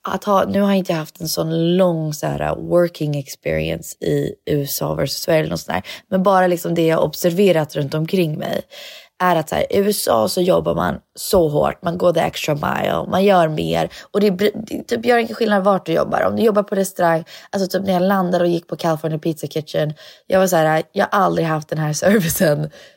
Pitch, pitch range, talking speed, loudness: 175 Hz, 155-195 Hz, 225 wpm, -18 LUFS